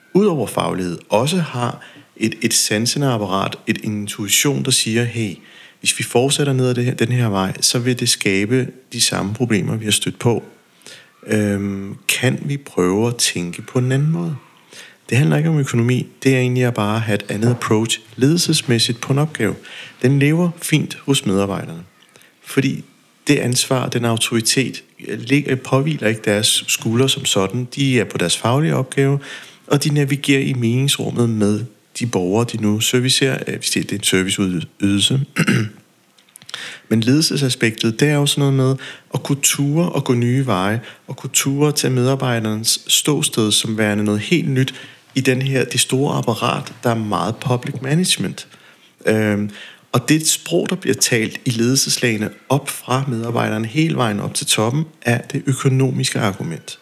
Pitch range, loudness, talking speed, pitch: 110-140 Hz, -18 LUFS, 165 wpm, 125 Hz